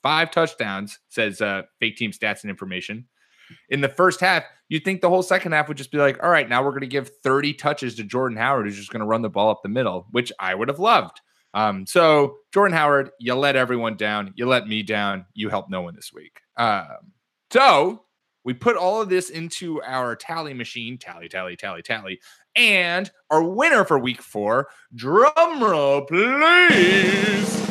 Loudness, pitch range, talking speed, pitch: -20 LUFS, 115-175 Hz, 200 wpm, 140 Hz